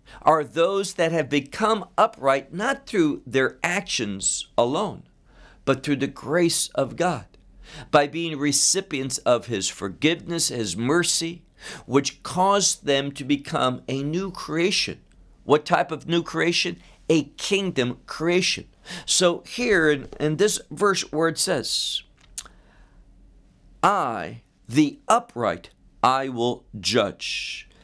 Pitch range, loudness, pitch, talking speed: 135-175 Hz, -23 LUFS, 155 Hz, 120 wpm